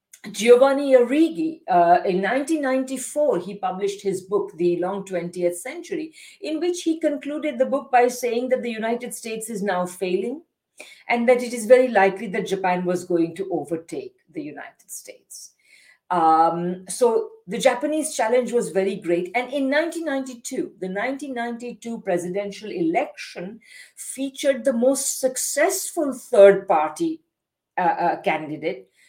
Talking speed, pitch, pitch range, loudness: 140 wpm, 245 Hz, 195-290 Hz, -22 LUFS